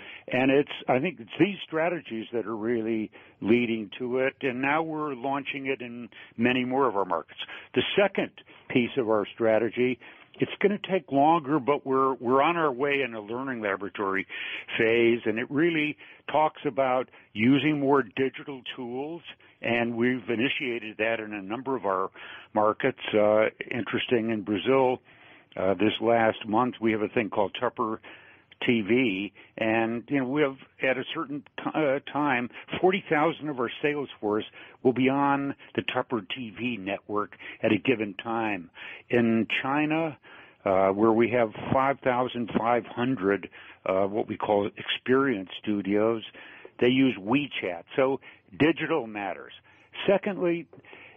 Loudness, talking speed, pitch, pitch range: -27 LUFS, 150 wpm, 125 Hz, 110-140 Hz